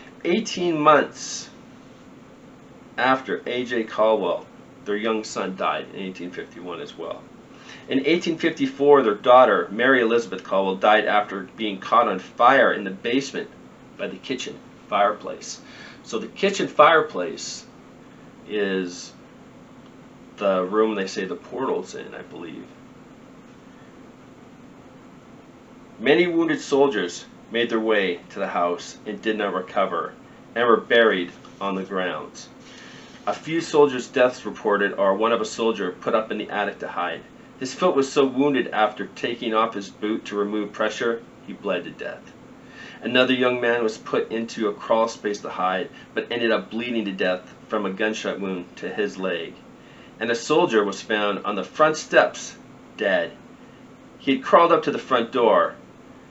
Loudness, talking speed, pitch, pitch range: -22 LUFS, 150 wpm, 110 Hz, 100-130 Hz